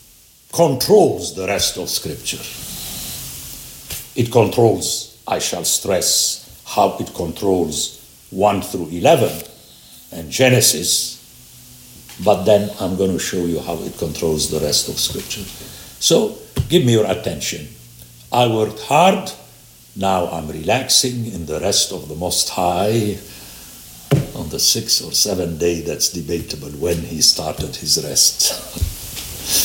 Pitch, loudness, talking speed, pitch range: 95 Hz, -17 LUFS, 125 wpm, 80-120 Hz